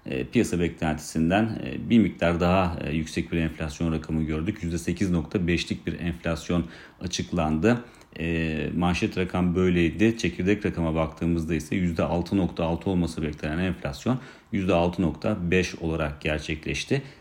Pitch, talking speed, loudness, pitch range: 85 Hz, 100 wpm, -26 LUFS, 80-95 Hz